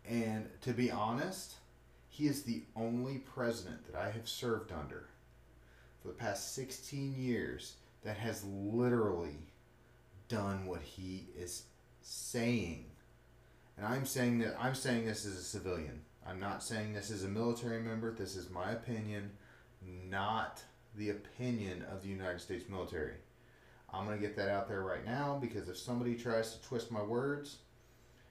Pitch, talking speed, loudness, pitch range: 110 Hz, 155 wpm, -40 LUFS, 95-120 Hz